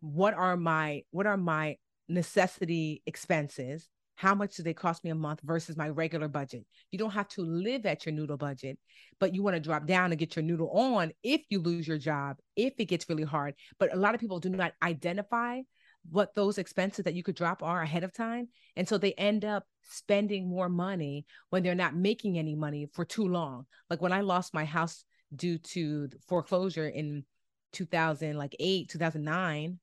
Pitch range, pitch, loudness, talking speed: 155-190 Hz, 170 Hz, -32 LUFS, 200 wpm